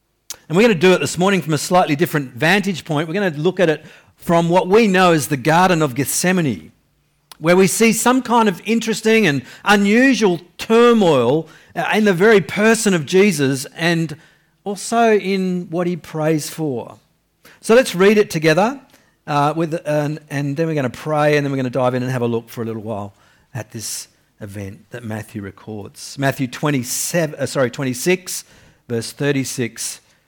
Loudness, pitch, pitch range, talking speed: -17 LUFS, 160 Hz, 135-195 Hz, 185 wpm